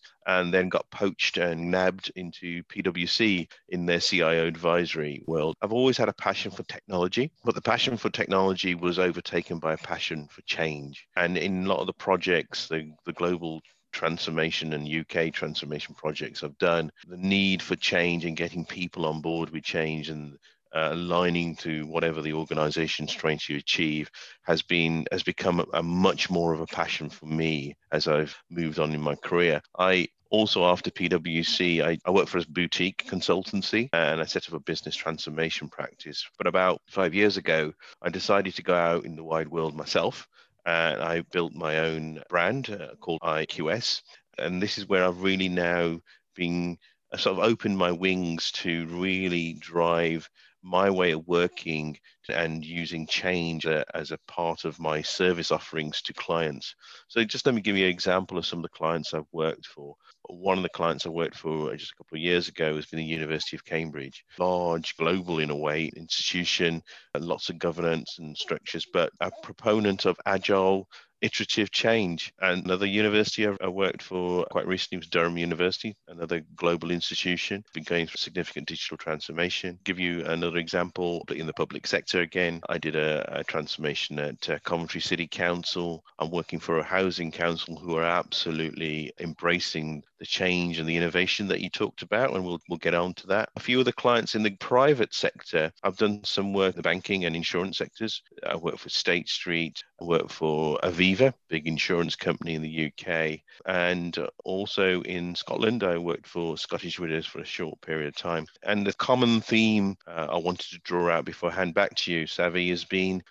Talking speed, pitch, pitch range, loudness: 185 wpm, 85 Hz, 80-90 Hz, -27 LUFS